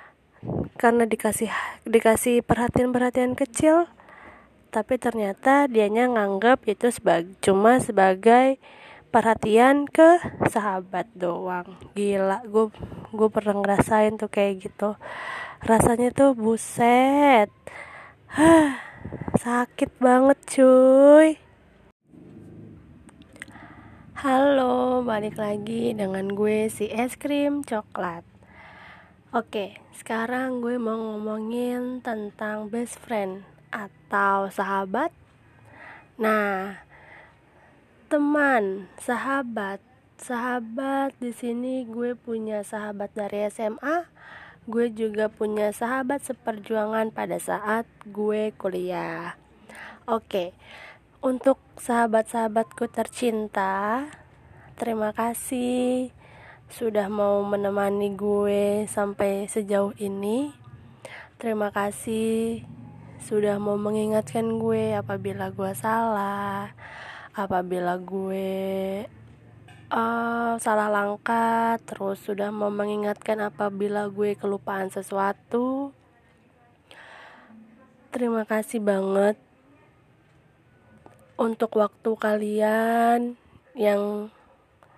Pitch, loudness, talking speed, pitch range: 220 Hz, -24 LUFS, 80 wpm, 200-240 Hz